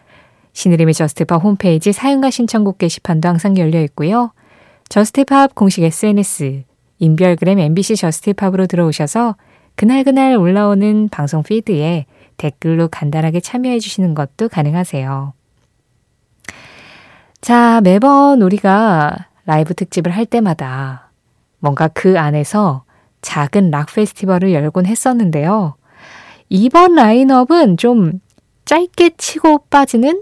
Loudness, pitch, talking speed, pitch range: -13 LUFS, 185 Hz, 280 characters per minute, 155-225 Hz